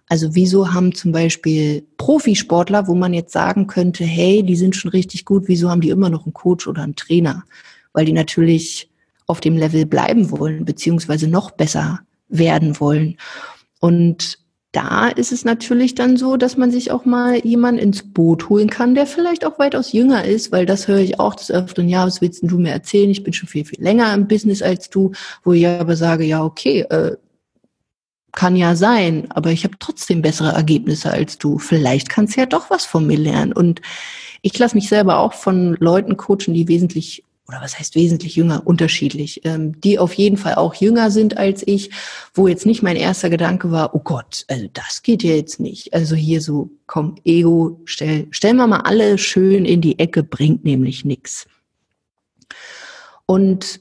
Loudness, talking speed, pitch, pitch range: -16 LUFS, 195 wpm, 180 Hz, 160-200 Hz